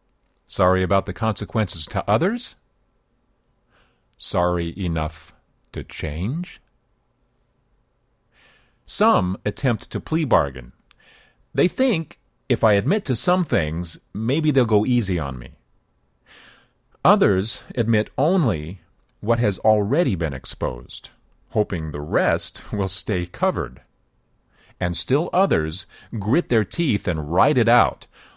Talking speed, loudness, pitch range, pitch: 110 wpm, -22 LUFS, 85-120 Hz, 105 Hz